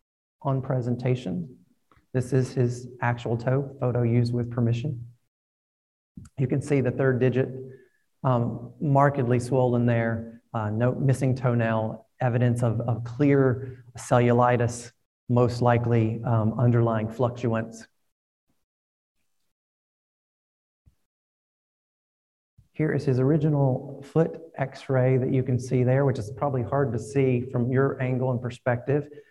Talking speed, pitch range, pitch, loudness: 120 wpm, 120-135 Hz, 125 Hz, -25 LUFS